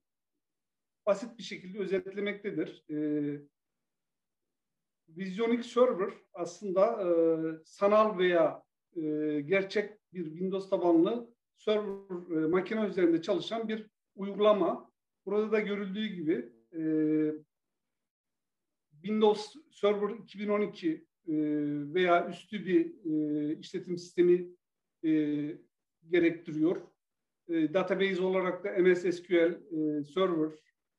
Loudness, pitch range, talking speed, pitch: -31 LUFS, 160-205 Hz, 95 wpm, 185 Hz